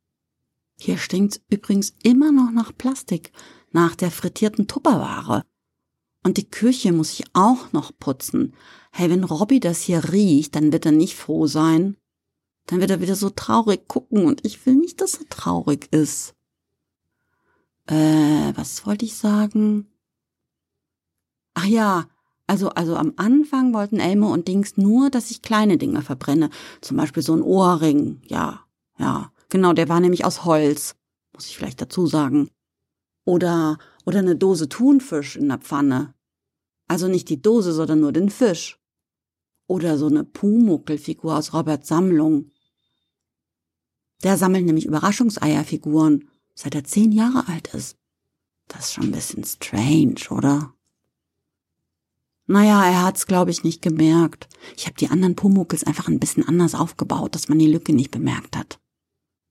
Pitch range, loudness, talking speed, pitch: 150-205 Hz, -20 LUFS, 150 wpm, 170 Hz